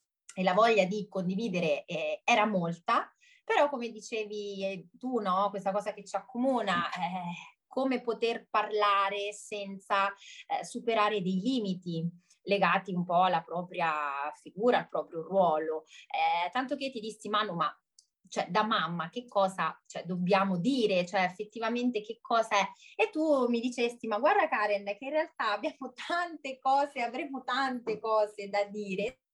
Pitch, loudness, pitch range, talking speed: 210 Hz, -31 LUFS, 190-245 Hz, 155 wpm